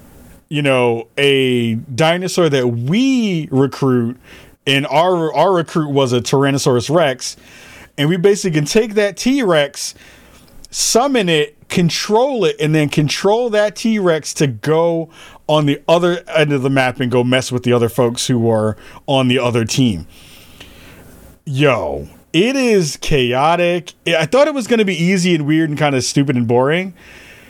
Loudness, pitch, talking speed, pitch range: -15 LUFS, 145 Hz, 160 wpm, 125-175 Hz